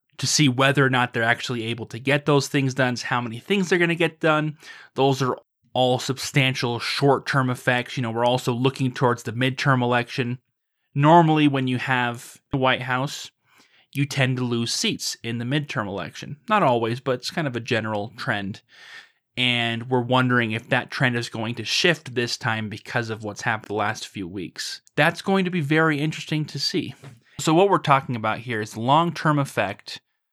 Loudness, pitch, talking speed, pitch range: -22 LUFS, 130 Hz, 195 wpm, 120-140 Hz